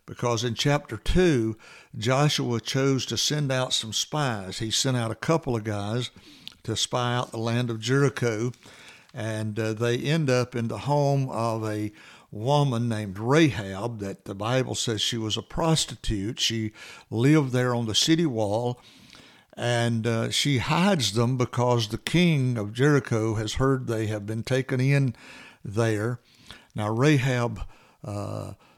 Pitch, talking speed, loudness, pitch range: 120 Hz, 155 wpm, -25 LUFS, 110-130 Hz